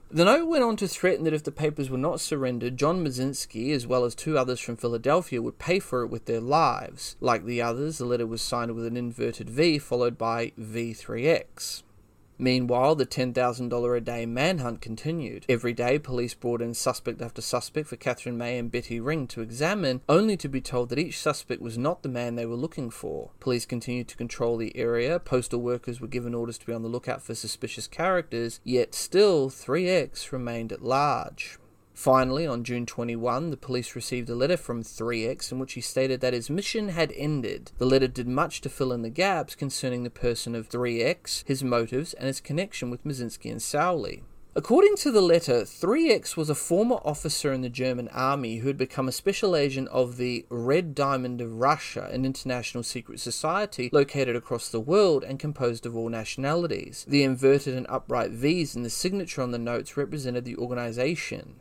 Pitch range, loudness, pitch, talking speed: 120-145 Hz, -27 LUFS, 125 Hz, 200 wpm